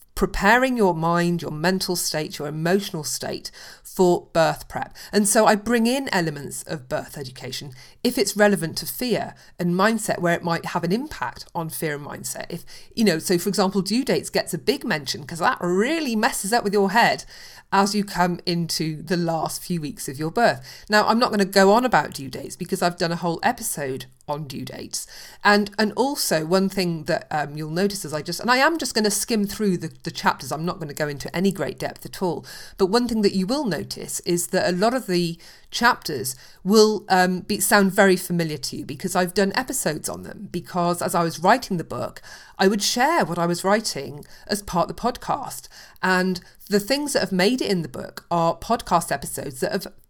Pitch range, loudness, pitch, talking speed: 165-210 Hz, -22 LUFS, 185 Hz, 220 wpm